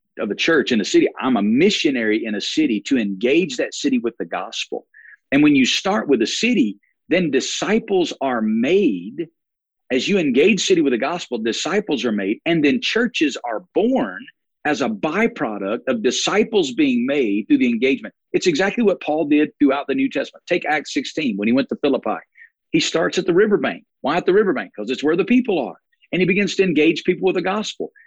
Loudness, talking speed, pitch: -19 LUFS, 205 wpm, 220 Hz